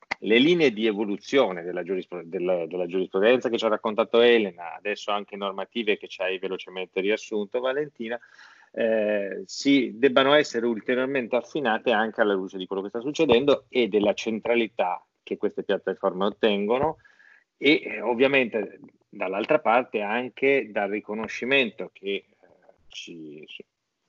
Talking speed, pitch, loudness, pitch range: 135 wpm, 115 Hz, -25 LUFS, 100-130 Hz